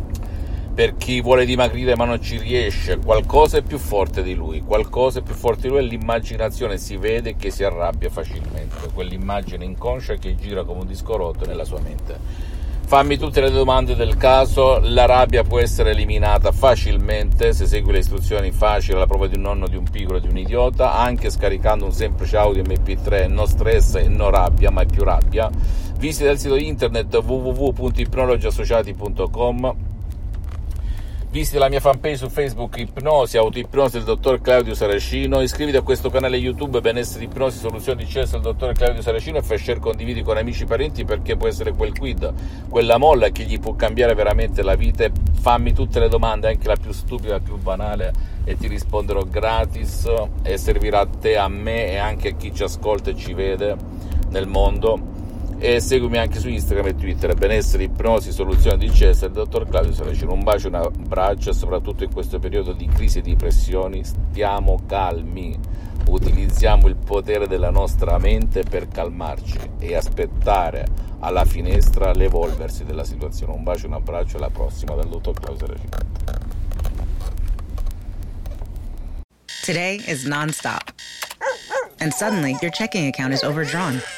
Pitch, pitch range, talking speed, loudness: 95 Hz, 85-115 Hz, 165 wpm, -20 LUFS